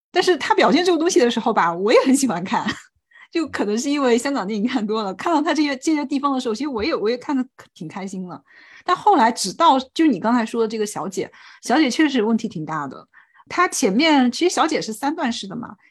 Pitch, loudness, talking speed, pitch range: 260 Hz, -19 LUFS, 350 characters per minute, 225-320 Hz